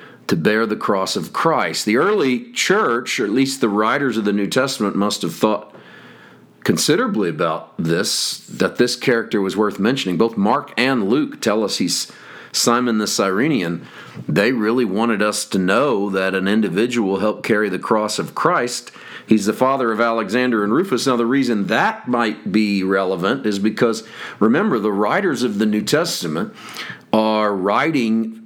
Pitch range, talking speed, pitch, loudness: 105-120 Hz, 170 wpm, 110 Hz, -18 LUFS